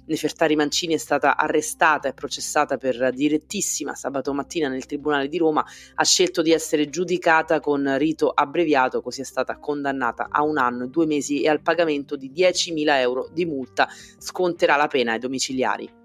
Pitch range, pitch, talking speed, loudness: 135-160 Hz, 150 Hz, 170 wpm, -22 LUFS